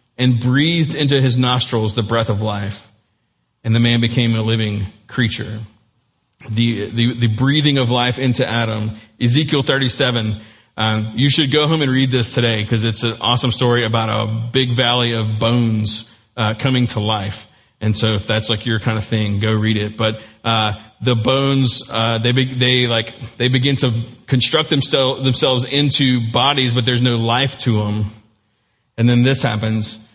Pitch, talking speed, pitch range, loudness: 115 Hz, 175 wpm, 110-130 Hz, -16 LUFS